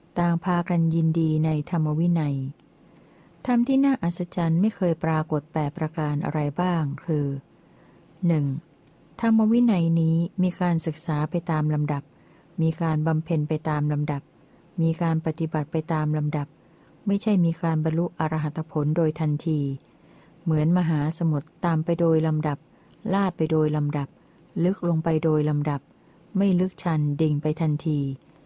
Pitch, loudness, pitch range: 160 Hz, -25 LUFS, 150-170 Hz